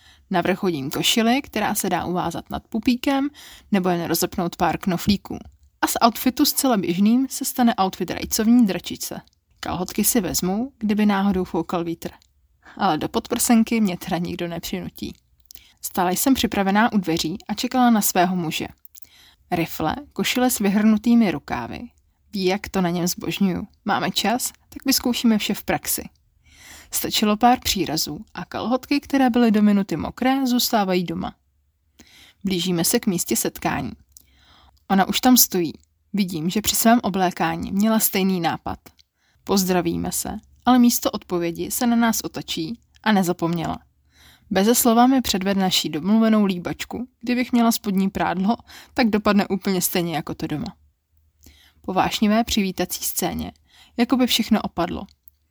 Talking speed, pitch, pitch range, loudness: 145 wpm, 195 Hz, 170-235 Hz, -21 LUFS